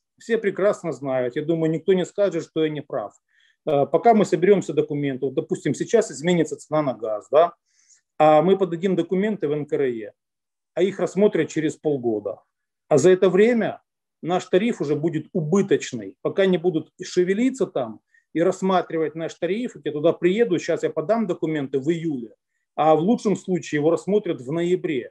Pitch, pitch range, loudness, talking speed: 170 Hz, 155-195 Hz, -22 LUFS, 165 wpm